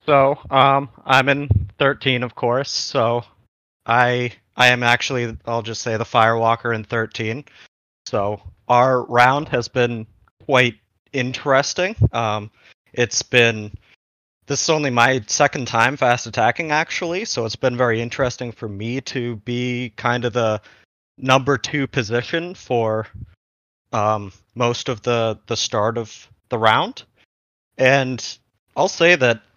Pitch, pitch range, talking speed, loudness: 120 Hz, 110-130 Hz, 135 wpm, -19 LUFS